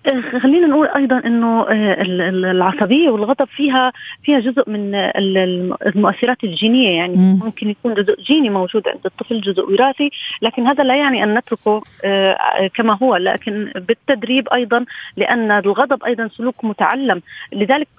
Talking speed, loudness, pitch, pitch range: 130 wpm, -16 LUFS, 230 Hz, 200-260 Hz